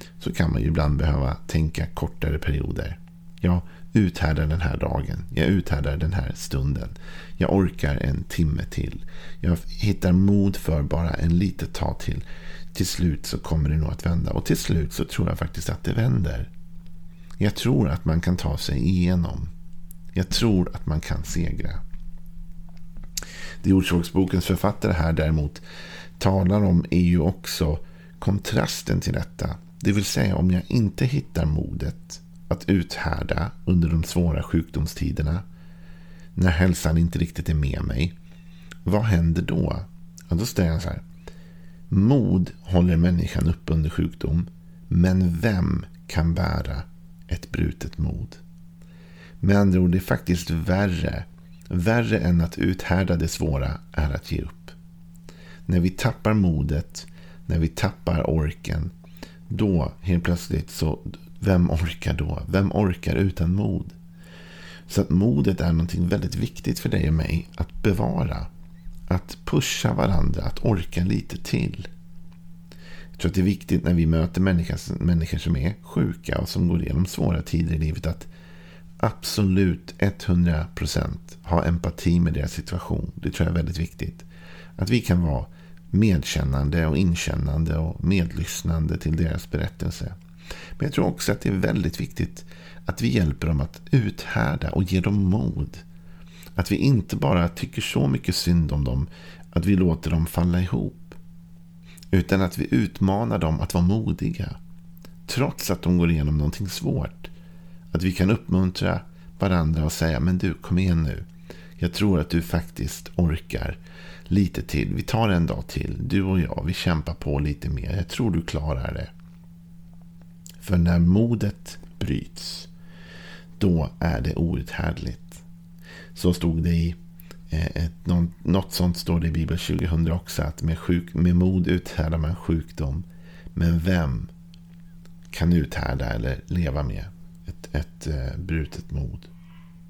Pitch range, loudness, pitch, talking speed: 85-90 Hz, -24 LUFS, 85 Hz, 150 wpm